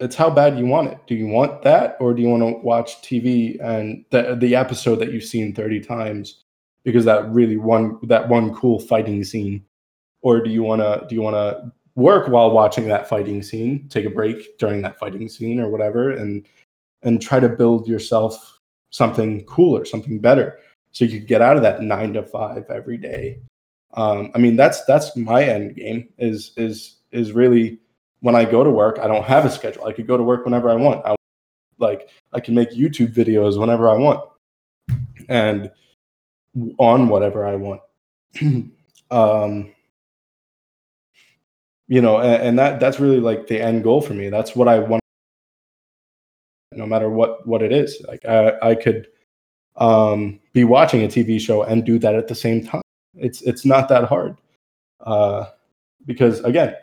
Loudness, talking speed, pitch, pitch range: -18 LUFS, 185 wpm, 115 Hz, 110-120 Hz